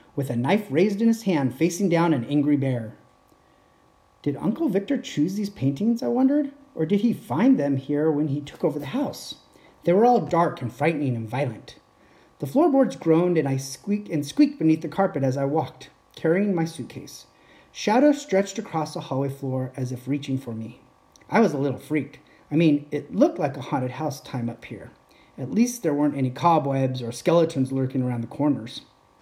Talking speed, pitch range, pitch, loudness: 195 wpm, 135-195 Hz, 150 Hz, -24 LUFS